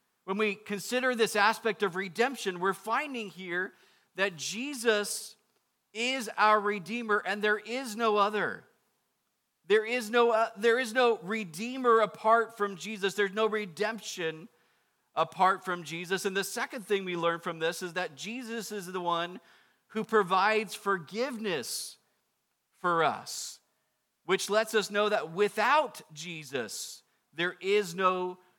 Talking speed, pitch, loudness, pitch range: 140 wpm, 210 Hz, -30 LUFS, 190-225 Hz